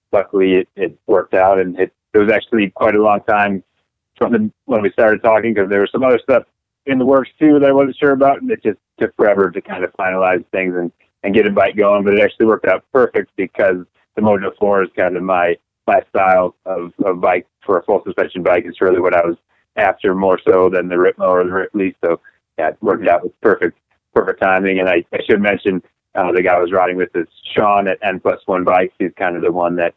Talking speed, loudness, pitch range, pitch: 245 wpm, -15 LUFS, 90-105 Hz, 95 Hz